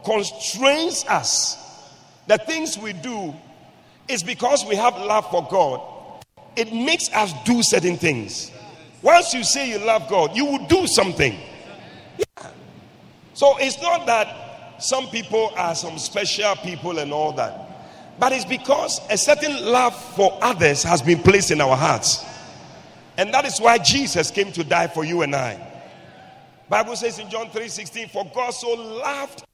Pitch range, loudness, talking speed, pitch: 185-265 Hz, -20 LUFS, 160 wpm, 220 Hz